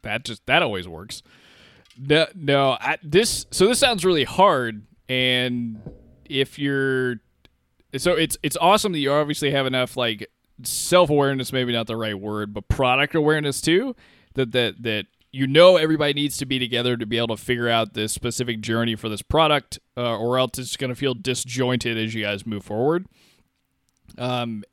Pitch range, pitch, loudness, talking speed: 115-145 Hz, 125 Hz, -21 LUFS, 175 wpm